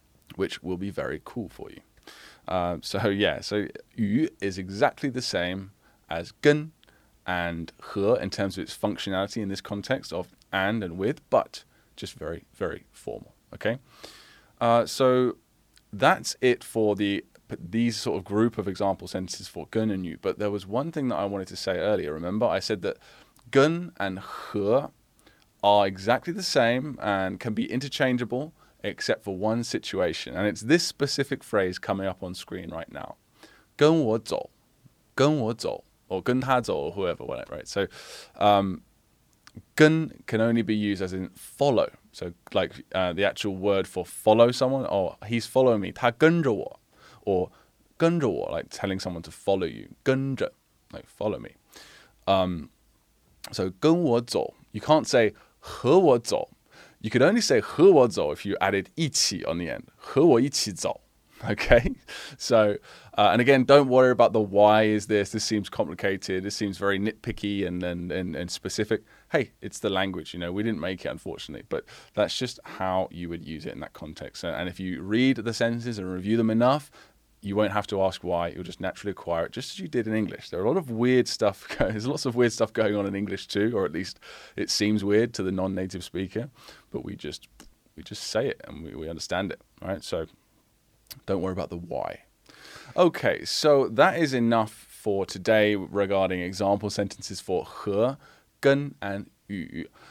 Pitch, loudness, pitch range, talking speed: 105 Hz, -26 LUFS, 95-125 Hz, 175 wpm